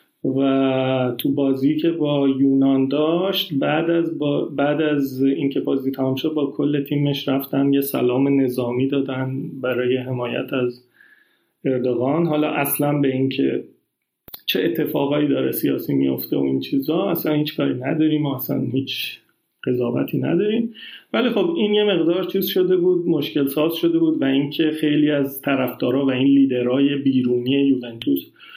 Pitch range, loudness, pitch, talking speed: 130-150 Hz, -20 LUFS, 140 Hz, 145 wpm